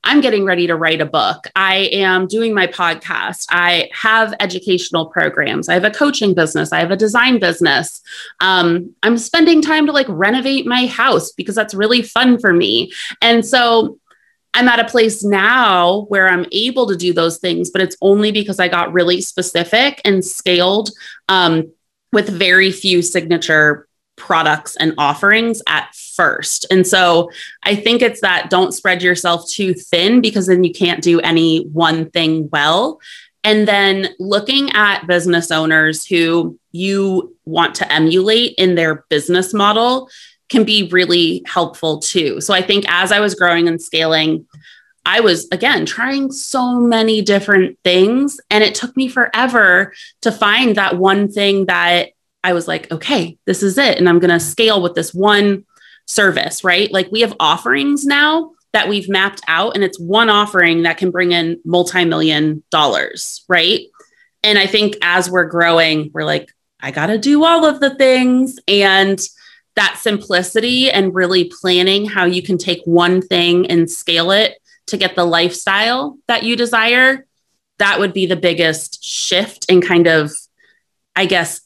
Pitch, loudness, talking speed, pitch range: 190 Hz, -13 LUFS, 170 wpm, 175-225 Hz